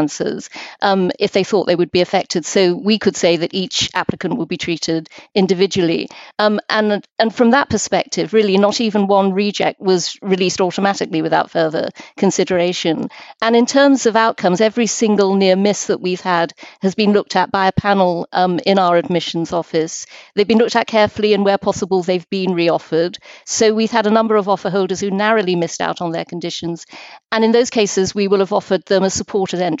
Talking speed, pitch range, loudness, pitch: 200 wpm, 180-210 Hz, -16 LUFS, 195 Hz